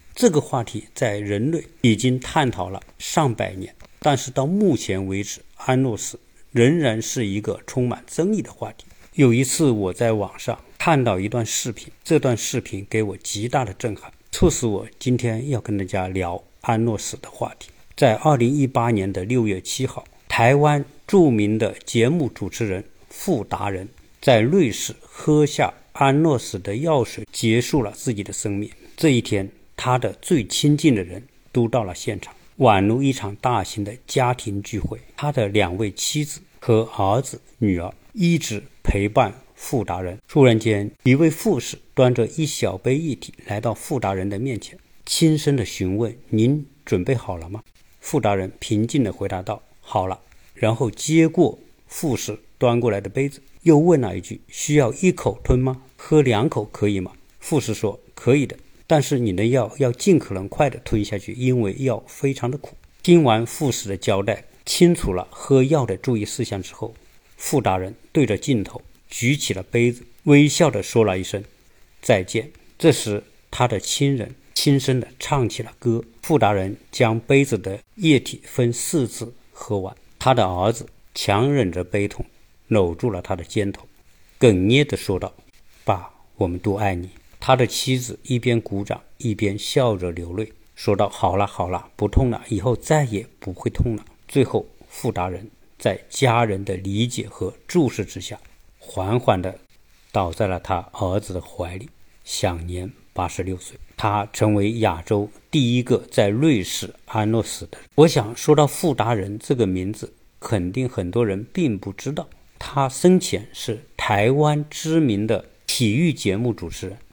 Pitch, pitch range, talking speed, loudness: 115 Hz, 100-135 Hz, 245 characters per minute, -21 LUFS